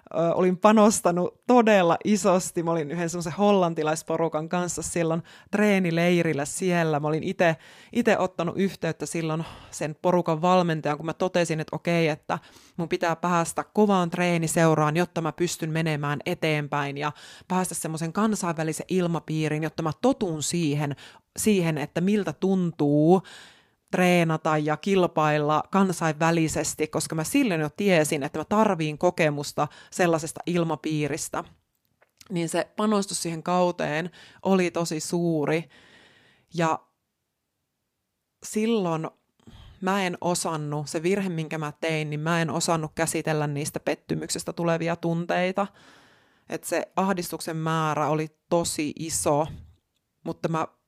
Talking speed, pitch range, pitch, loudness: 120 wpm, 155-180 Hz, 165 Hz, -25 LUFS